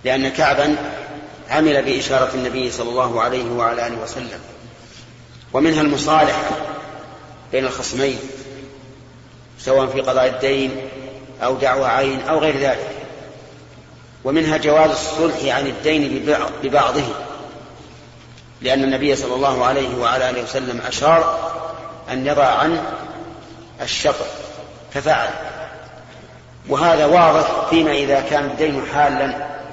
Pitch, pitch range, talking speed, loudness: 135 Hz, 130-155 Hz, 105 wpm, -18 LUFS